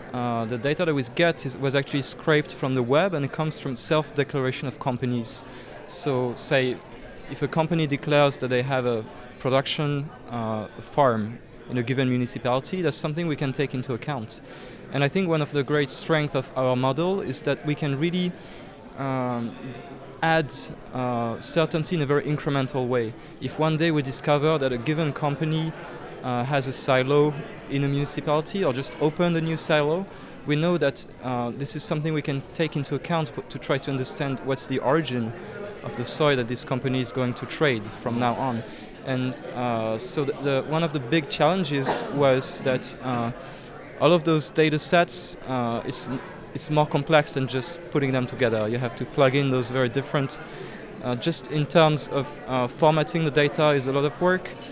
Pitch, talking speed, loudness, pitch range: 140 Hz, 190 wpm, -25 LUFS, 125-155 Hz